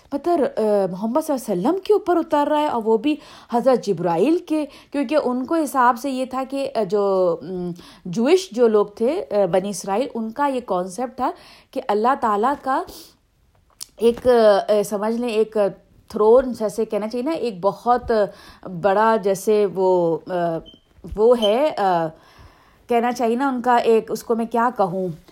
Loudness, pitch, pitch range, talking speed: -20 LUFS, 230 Hz, 200-265 Hz, 160 wpm